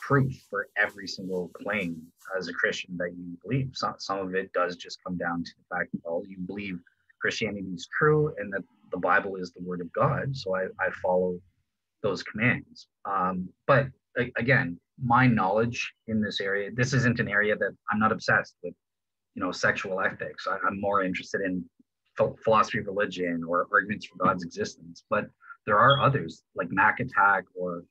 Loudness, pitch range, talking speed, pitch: -27 LUFS, 90-110 Hz, 190 wpm, 95 Hz